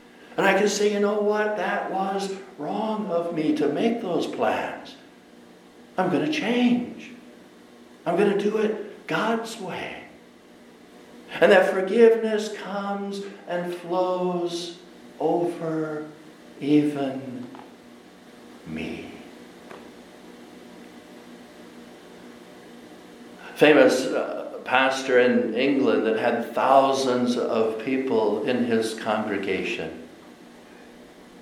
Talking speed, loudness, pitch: 95 wpm, -23 LUFS, 135 Hz